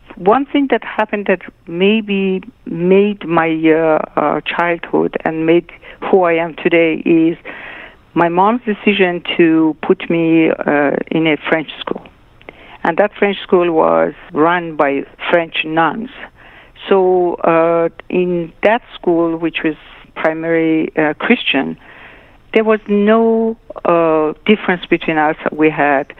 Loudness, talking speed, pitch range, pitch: -14 LUFS, 135 wpm, 160-205 Hz, 170 Hz